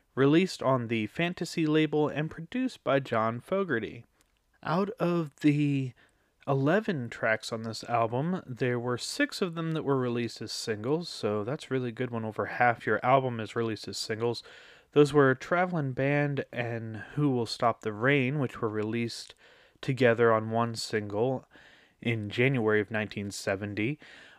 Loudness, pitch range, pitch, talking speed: -29 LUFS, 115-150 Hz, 125 Hz, 155 wpm